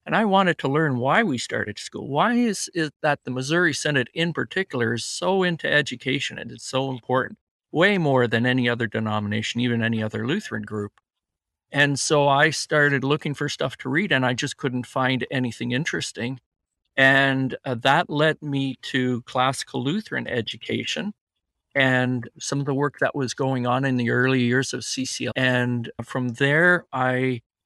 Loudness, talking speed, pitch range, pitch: -23 LUFS, 180 wpm, 125-145 Hz, 130 Hz